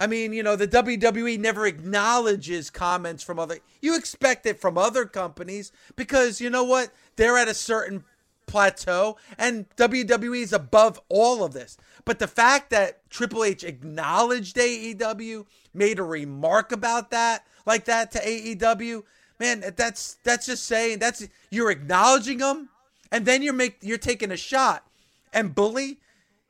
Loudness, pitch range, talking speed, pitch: -23 LUFS, 205-245 Hz, 155 wpm, 225 Hz